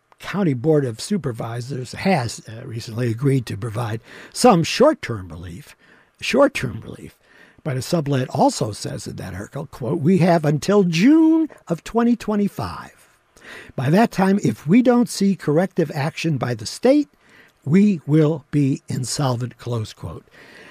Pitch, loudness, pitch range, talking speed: 155 Hz, -20 LUFS, 125-195 Hz, 140 wpm